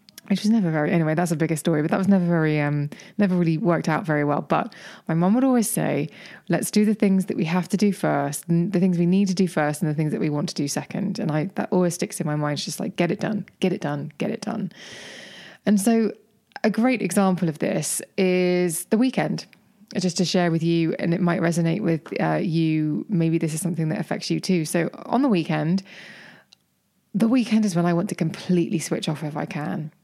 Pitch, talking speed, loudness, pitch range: 180 Hz, 240 wpm, -23 LUFS, 165-200 Hz